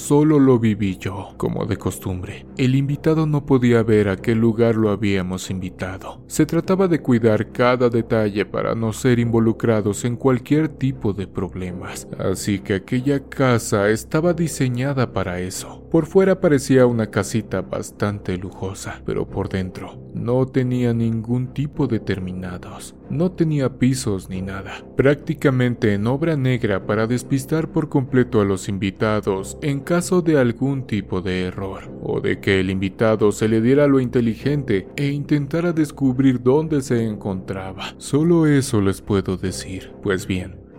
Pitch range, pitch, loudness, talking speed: 95-135 Hz, 115 Hz, -20 LUFS, 150 wpm